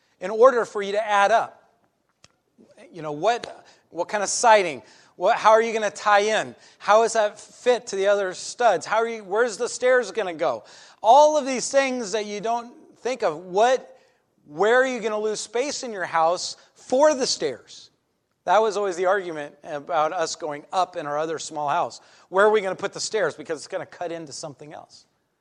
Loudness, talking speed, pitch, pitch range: -22 LUFS, 215 wpm, 205 Hz, 170-240 Hz